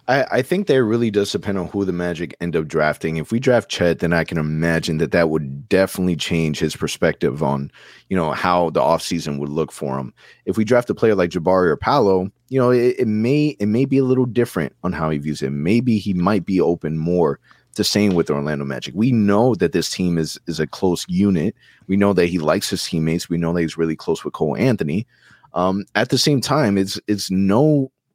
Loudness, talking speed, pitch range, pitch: -19 LUFS, 230 wpm, 80-115 Hz, 95 Hz